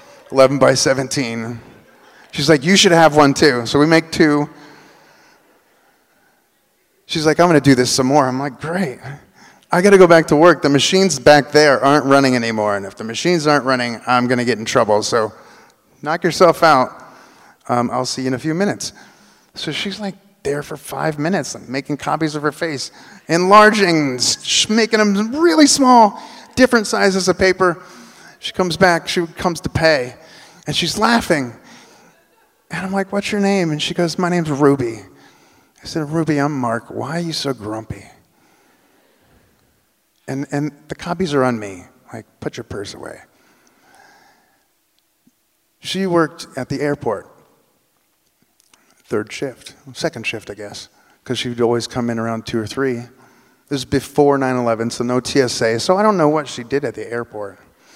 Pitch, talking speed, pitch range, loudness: 145 Hz, 175 wpm, 125-175 Hz, -16 LUFS